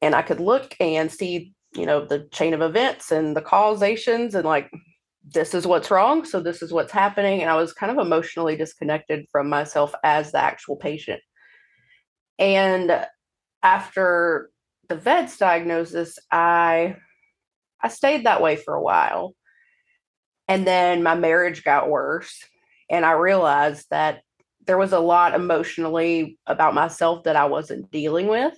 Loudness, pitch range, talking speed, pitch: -21 LUFS, 160-190 Hz, 155 wpm, 170 Hz